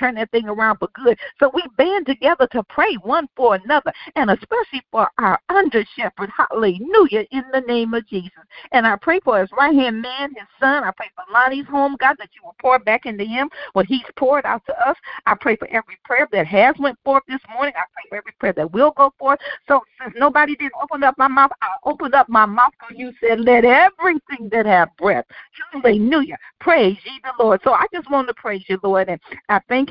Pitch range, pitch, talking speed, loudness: 225-285 Hz, 265 Hz, 225 wpm, -17 LUFS